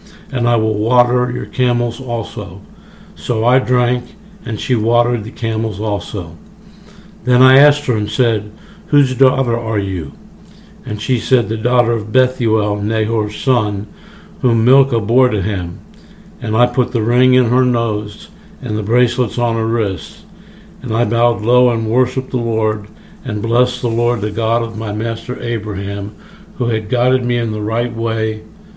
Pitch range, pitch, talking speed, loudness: 110-130 Hz, 120 Hz, 165 wpm, -16 LUFS